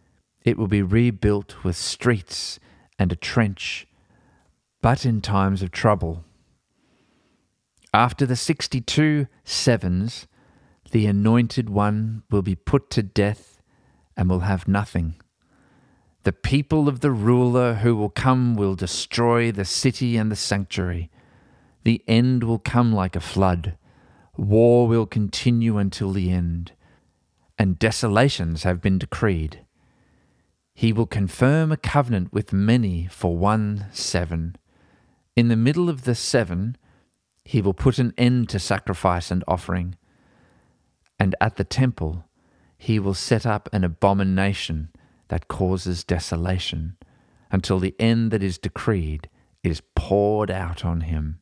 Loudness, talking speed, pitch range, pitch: -22 LUFS, 130 wpm, 90-120 Hz, 100 Hz